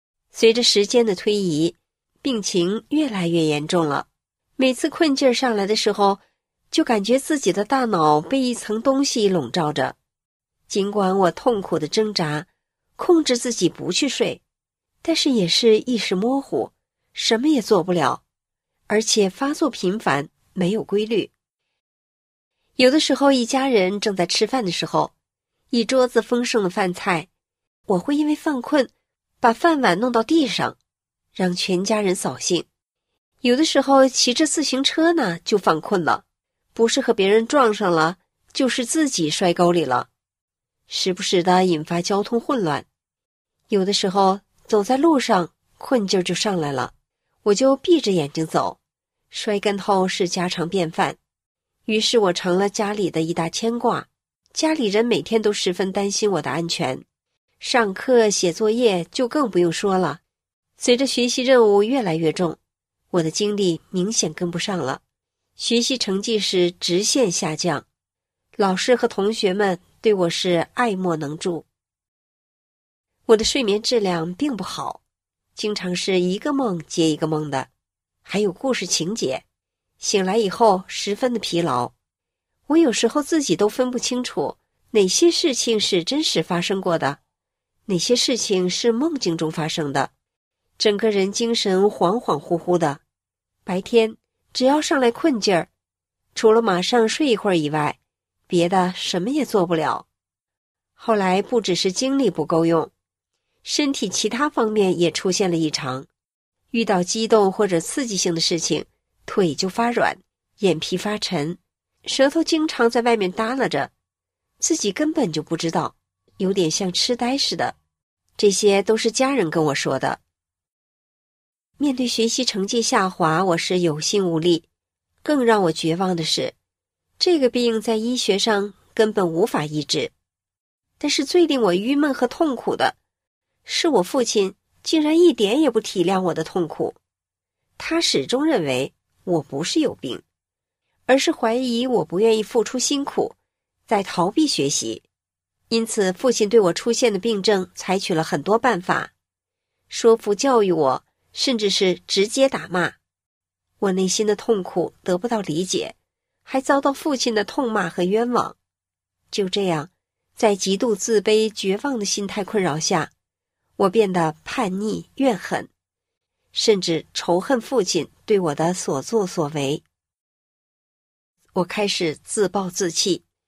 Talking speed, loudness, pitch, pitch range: 220 characters per minute, -20 LUFS, 205 Hz, 175-245 Hz